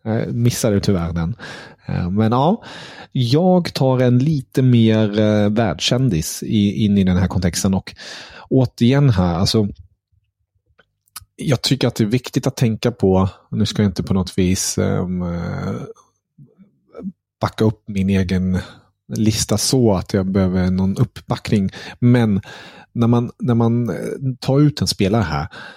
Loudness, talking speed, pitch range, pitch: -18 LUFS, 135 wpm, 95-125 Hz, 110 Hz